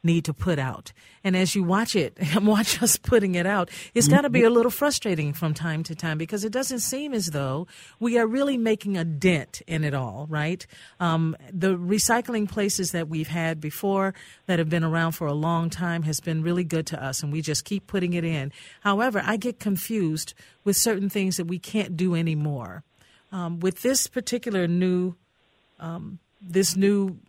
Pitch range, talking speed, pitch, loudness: 160-205 Hz, 200 wpm, 180 Hz, -25 LUFS